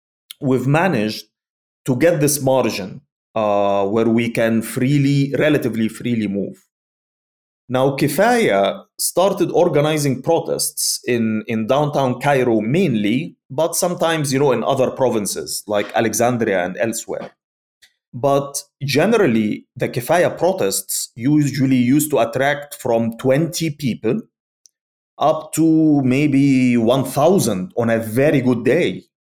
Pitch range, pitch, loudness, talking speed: 115-150 Hz, 135 Hz, -18 LUFS, 115 wpm